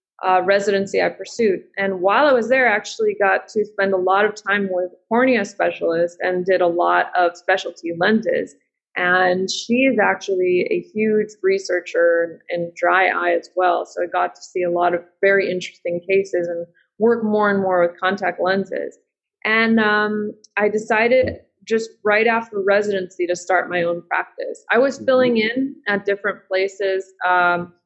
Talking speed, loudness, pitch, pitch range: 175 wpm, -19 LUFS, 195 Hz, 180-220 Hz